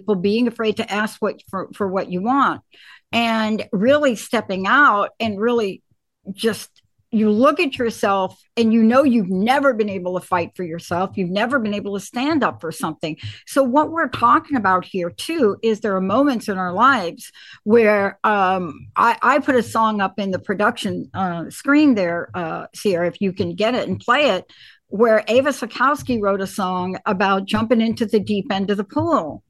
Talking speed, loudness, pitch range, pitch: 195 wpm, -19 LUFS, 190-240 Hz, 215 Hz